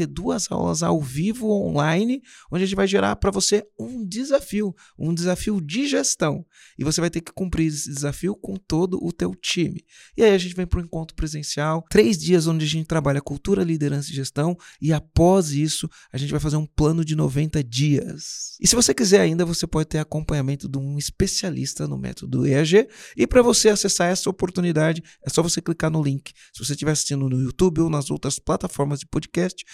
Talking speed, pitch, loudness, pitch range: 205 wpm, 165 Hz, -22 LUFS, 145-190 Hz